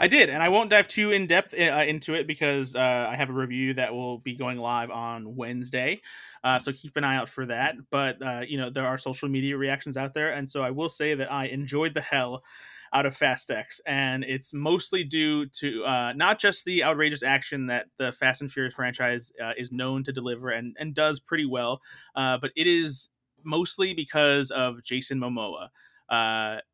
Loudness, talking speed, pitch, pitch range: -26 LUFS, 215 wpm, 135 Hz, 125-150 Hz